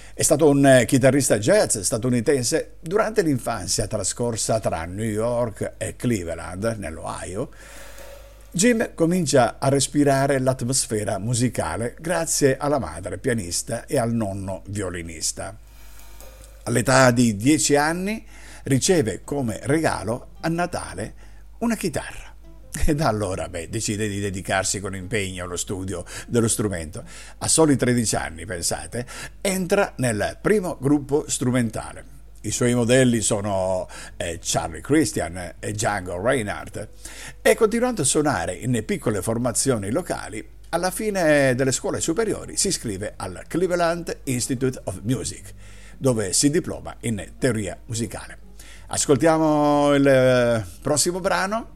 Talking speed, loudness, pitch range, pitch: 120 wpm, -22 LUFS, 105-145 Hz, 120 Hz